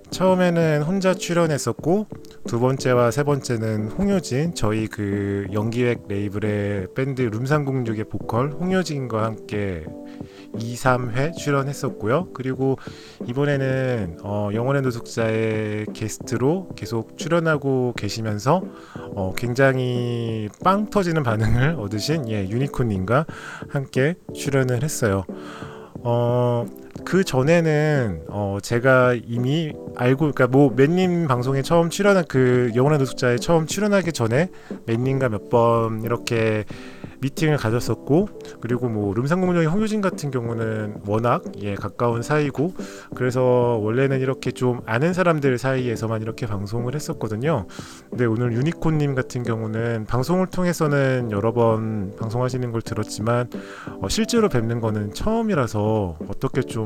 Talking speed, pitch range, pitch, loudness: 295 characters per minute, 110-150 Hz, 125 Hz, -22 LUFS